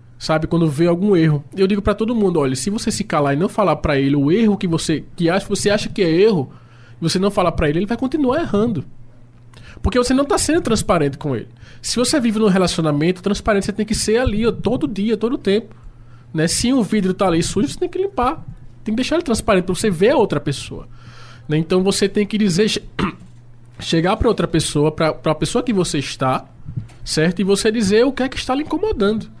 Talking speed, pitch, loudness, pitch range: 235 wpm, 185 Hz, -18 LUFS, 145-215 Hz